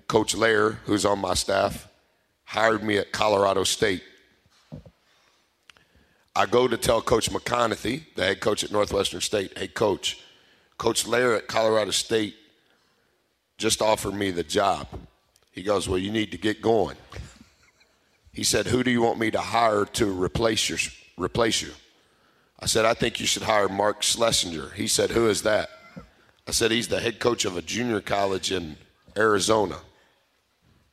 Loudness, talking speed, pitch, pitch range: -24 LUFS, 160 wpm, 105 Hz, 95-110 Hz